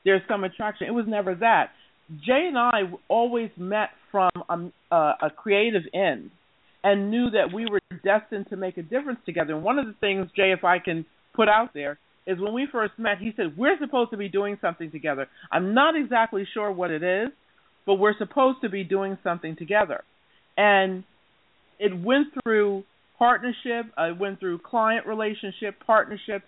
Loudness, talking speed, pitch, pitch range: -25 LUFS, 180 wpm, 205 Hz, 190-225 Hz